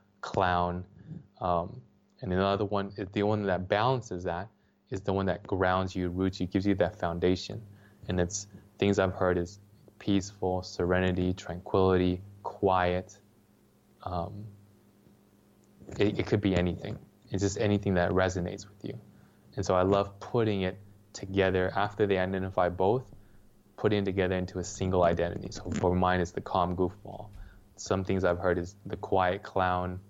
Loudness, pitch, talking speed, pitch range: -30 LUFS, 95 Hz, 155 wpm, 90-100 Hz